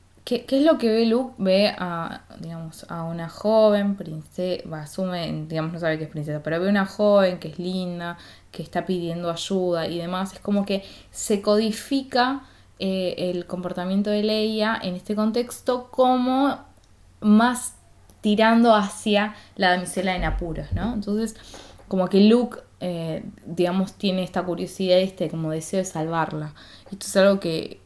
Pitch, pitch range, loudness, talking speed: 190 Hz, 170-215 Hz, -23 LUFS, 160 wpm